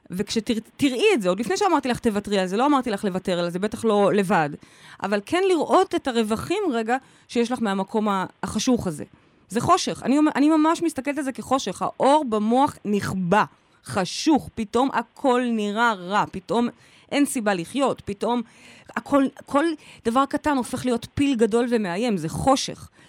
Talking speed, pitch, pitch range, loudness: 165 wpm, 235 Hz, 205-280 Hz, -23 LUFS